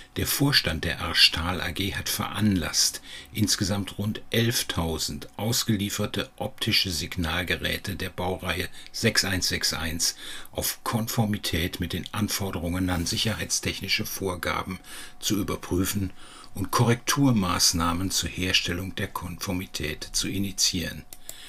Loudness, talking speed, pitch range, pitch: -26 LUFS, 95 wpm, 85-100 Hz, 95 Hz